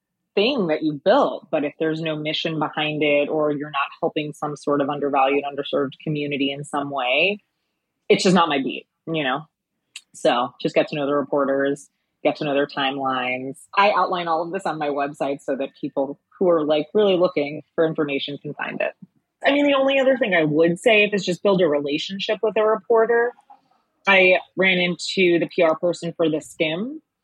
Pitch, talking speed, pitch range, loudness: 155 Hz, 200 wpm, 145-185 Hz, -21 LUFS